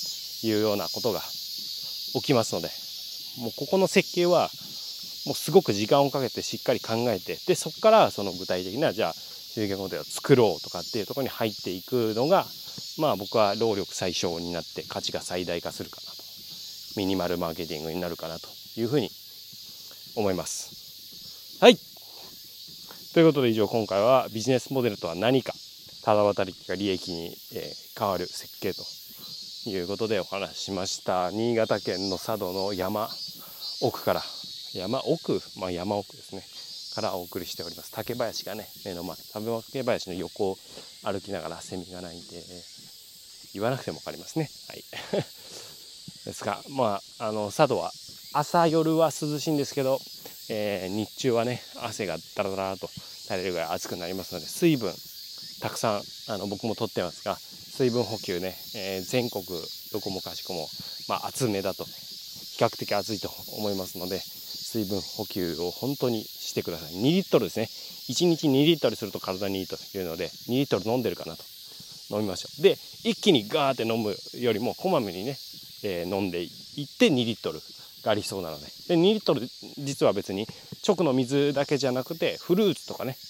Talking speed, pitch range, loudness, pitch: 335 characters per minute, 95-140 Hz, -28 LUFS, 110 Hz